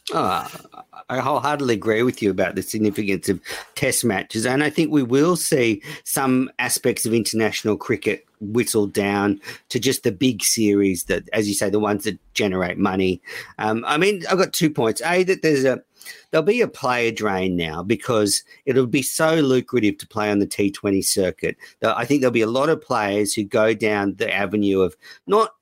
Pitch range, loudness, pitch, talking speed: 100-135 Hz, -21 LUFS, 110 Hz, 195 wpm